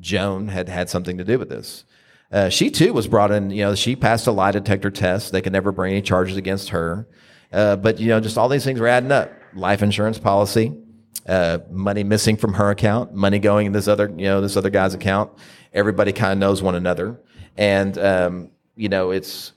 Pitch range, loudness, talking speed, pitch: 95-110 Hz, -19 LUFS, 220 wpm, 100 Hz